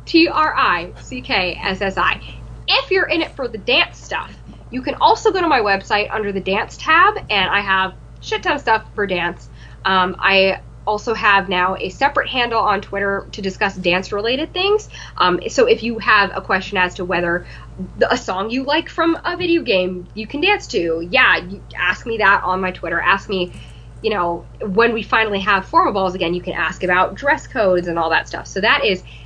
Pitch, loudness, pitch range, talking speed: 205 Hz, -17 LUFS, 185-280 Hz, 215 wpm